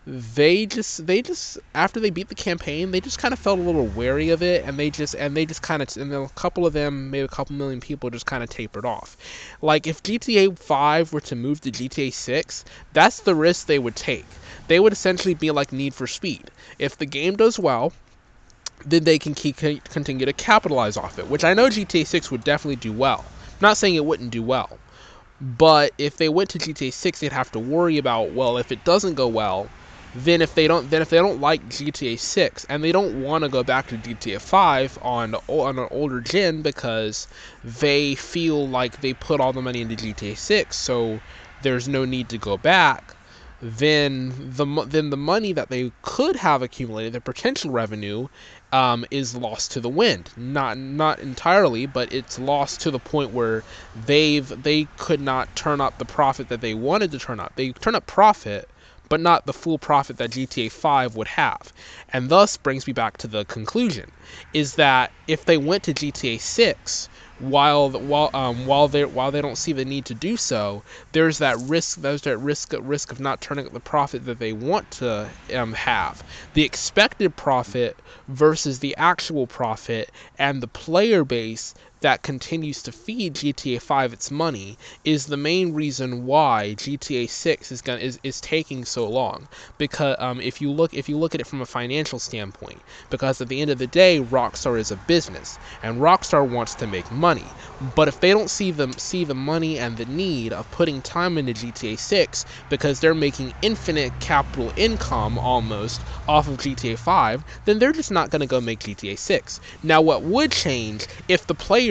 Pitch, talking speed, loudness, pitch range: 140 Hz, 200 wpm, -22 LUFS, 125-160 Hz